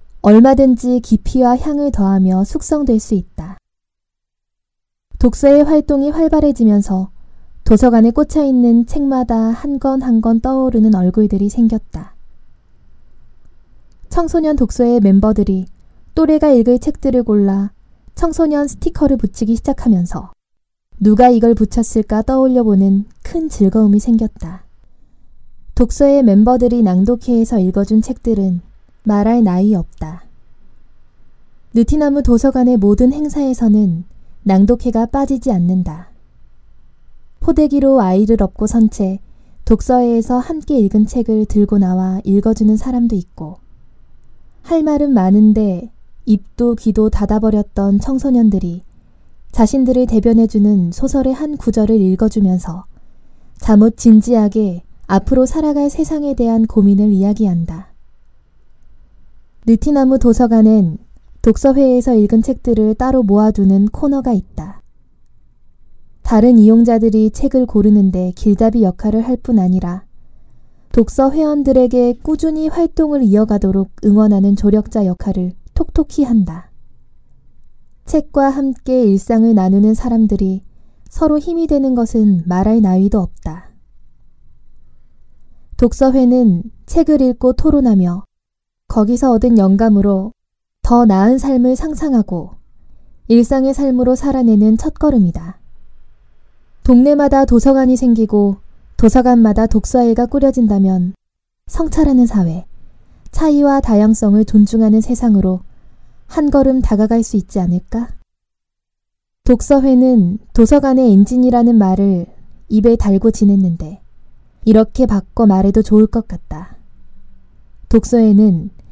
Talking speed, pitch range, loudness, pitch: 265 characters per minute, 200-260 Hz, -13 LUFS, 225 Hz